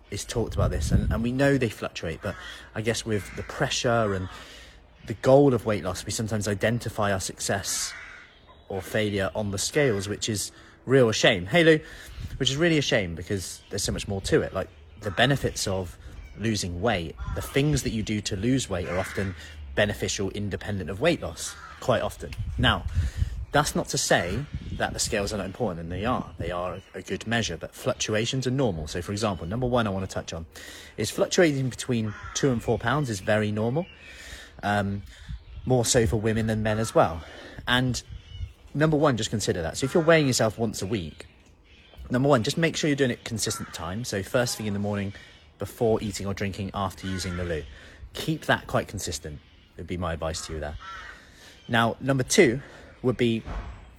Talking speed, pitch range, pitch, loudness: 200 wpm, 90-120 Hz, 105 Hz, -26 LUFS